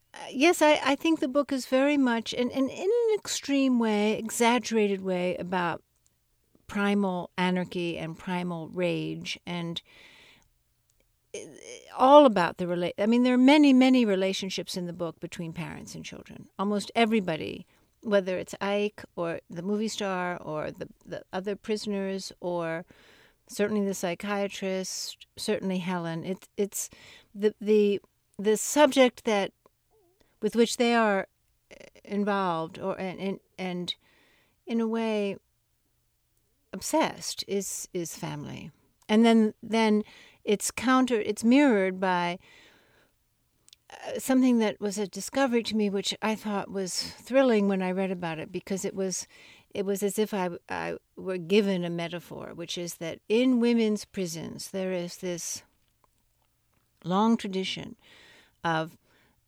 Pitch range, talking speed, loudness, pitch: 180-225 Hz, 135 wpm, -27 LUFS, 200 Hz